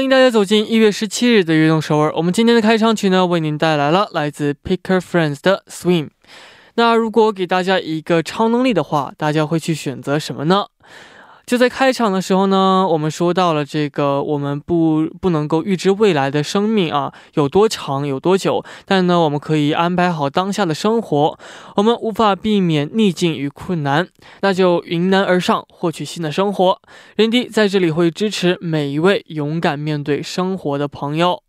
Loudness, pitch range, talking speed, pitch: -17 LUFS, 155-200 Hz, 310 characters per minute, 180 Hz